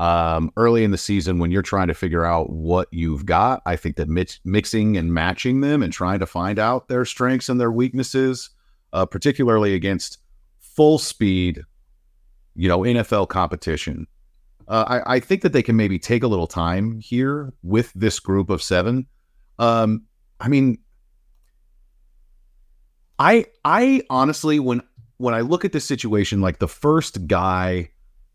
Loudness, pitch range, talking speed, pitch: -20 LUFS, 85-125 Hz, 160 wpm, 100 Hz